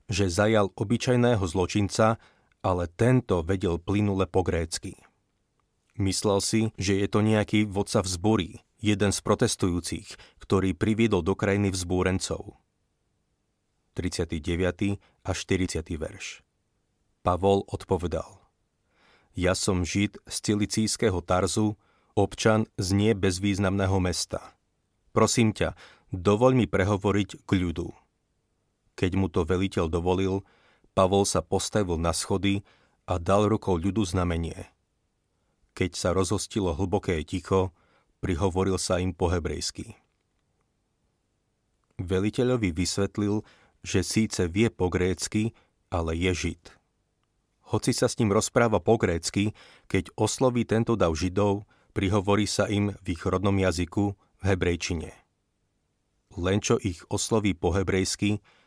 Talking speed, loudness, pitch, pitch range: 115 wpm, -26 LUFS, 100 Hz, 90-105 Hz